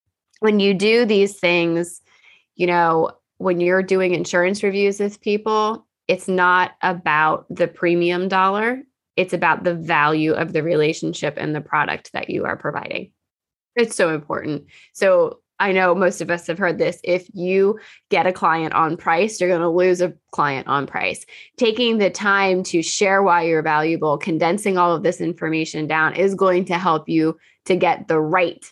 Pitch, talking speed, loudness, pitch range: 180 Hz, 175 wpm, -19 LUFS, 165-195 Hz